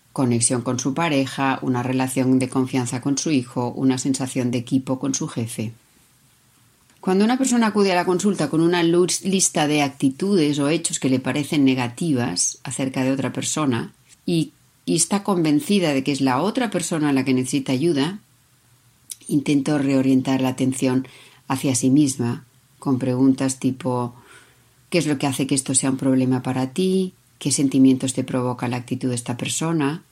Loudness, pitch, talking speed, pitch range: -21 LUFS, 135 Hz, 175 wpm, 130-150 Hz